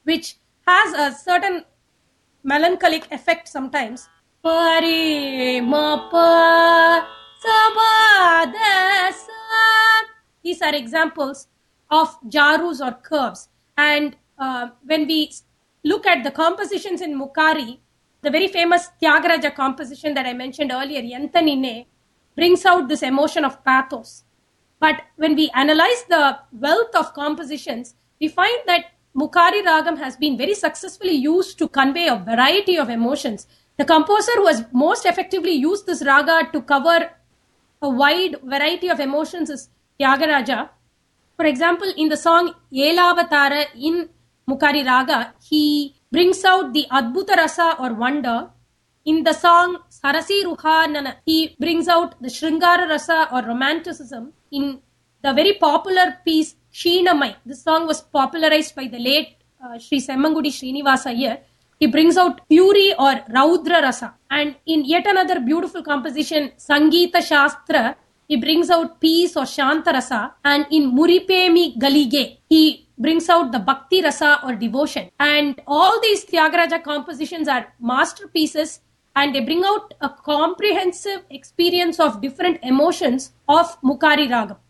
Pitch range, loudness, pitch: 280-340 Hz, -17 LUFS, 310 Hz